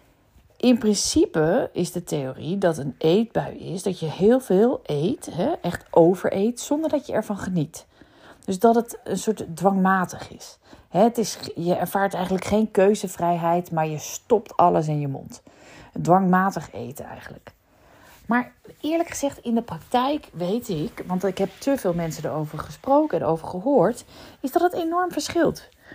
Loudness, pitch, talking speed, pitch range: -23 LUFS, 195 Hz, 155 wpm, 175-240 Hz